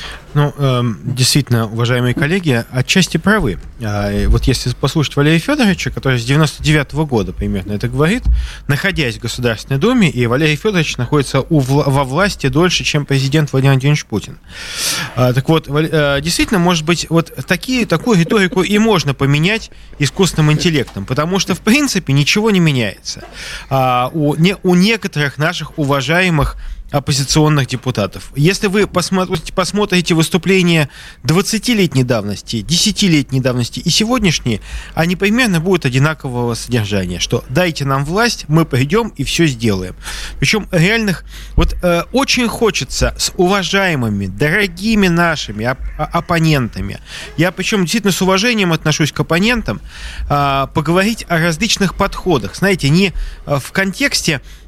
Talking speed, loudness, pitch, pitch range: 120 wpm, -14 LUFS, 155 Hz, 130-185 Hz